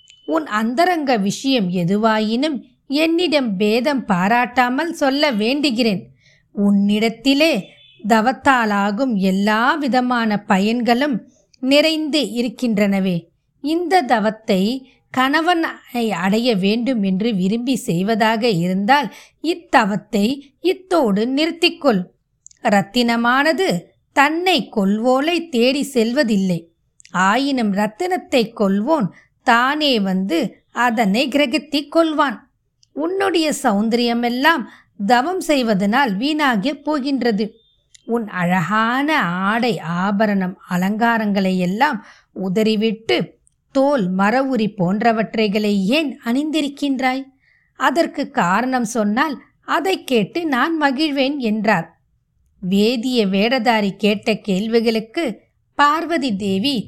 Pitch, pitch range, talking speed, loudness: 235 Hz, 205-280 Hz, 80 wpm, -18 LUFS